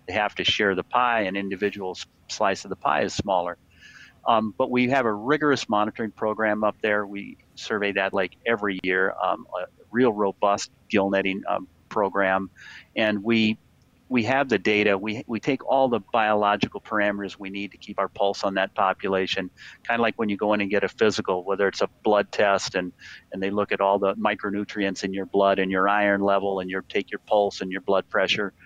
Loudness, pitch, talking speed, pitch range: -24 LUFS, 100 Hz, 210 wpm, 95-105 Hz